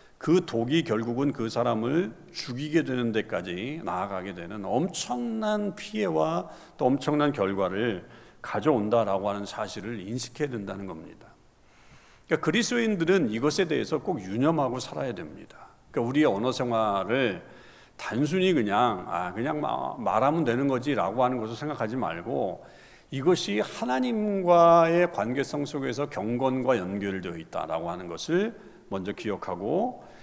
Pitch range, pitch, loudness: 110-165 Hz, 130 Hz, -27 LUFS